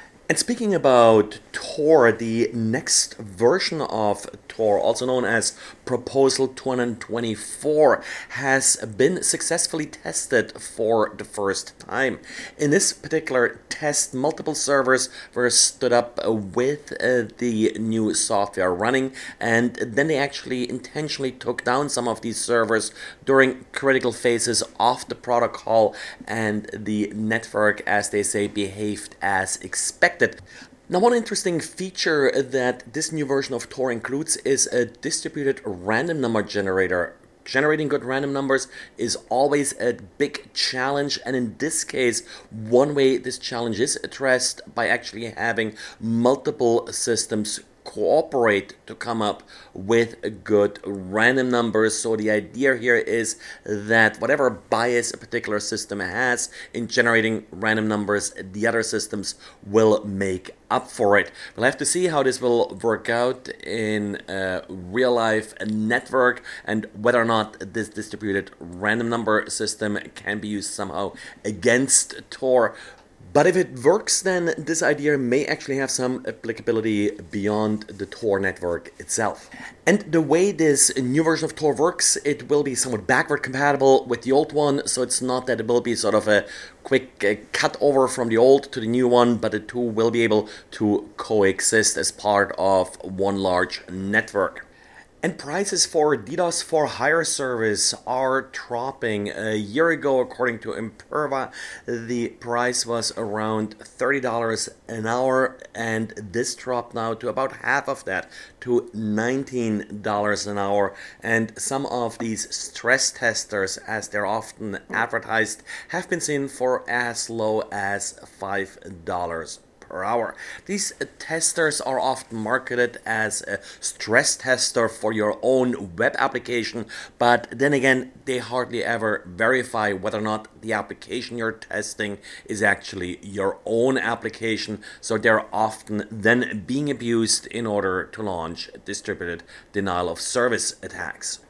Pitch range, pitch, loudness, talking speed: 110-135 Hz, 120 Hz, -22 LUFS, 145 wpm